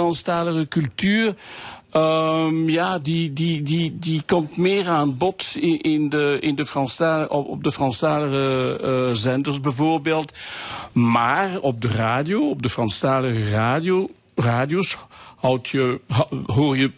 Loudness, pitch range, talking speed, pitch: -21 LUFS, 130-165 Hz, 130 wpm, 150 Hz